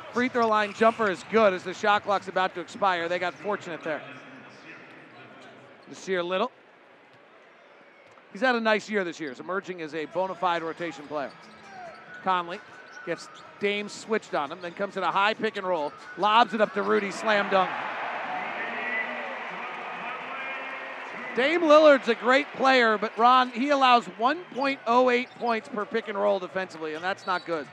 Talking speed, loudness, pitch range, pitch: 165 wpm, -26 LUFS, 185-235 Hz, 205 Hz